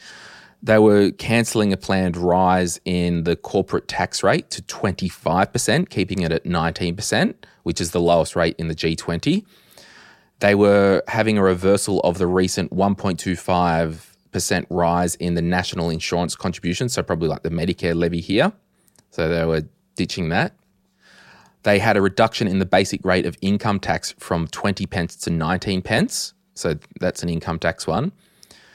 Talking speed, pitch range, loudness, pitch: 155 wpm, 85-100 Hz, -20 LUFS, 90 Hz